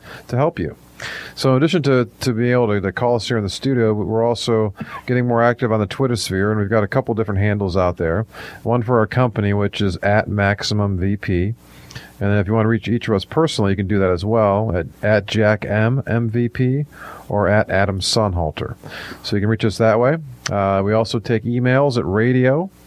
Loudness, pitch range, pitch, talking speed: -18 LUFS, 100-120 Hz, 110 Hz, 225 wpm